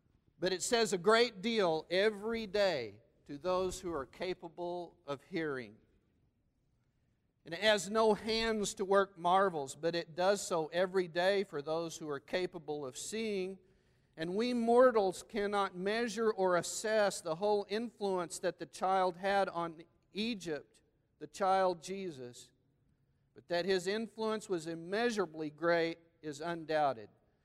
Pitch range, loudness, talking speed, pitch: 155-200 Hz, -34 LUFS, 140 wpm, 180 Hz